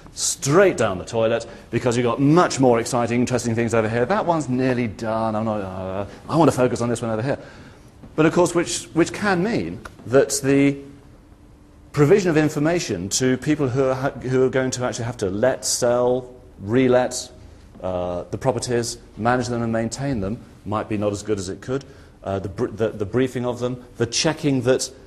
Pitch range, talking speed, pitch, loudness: 110-135 Hz, 200 wpm, 120 Hz, -21 LUFS